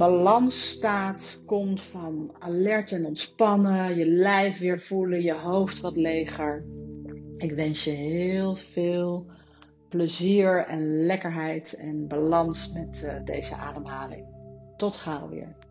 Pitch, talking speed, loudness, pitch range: 175 Hz, 120 wpm, -26 LUFS, 155-190 Hz